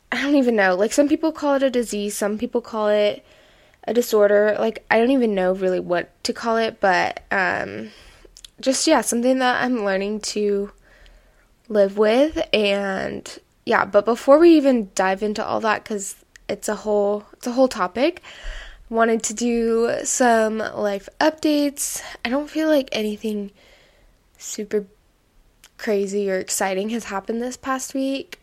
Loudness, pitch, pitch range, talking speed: -20 LUFS, 225 Hz, 205-265 Hz, 160 wpm